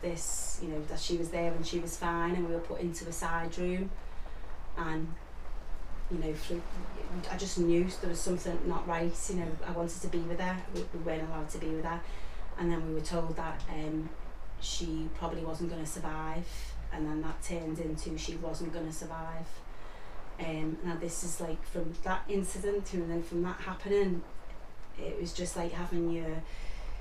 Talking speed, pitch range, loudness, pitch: 195 wpm, 160-175 Hz, -36 LUFS, 165 Hz